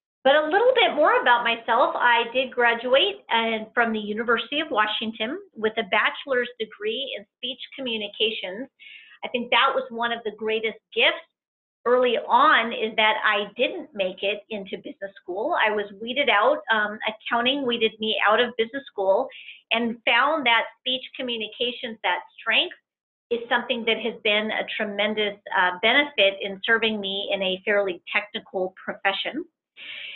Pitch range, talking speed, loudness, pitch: 210-260 Hz, 155 wpm, -23 LUFS, 230 Hz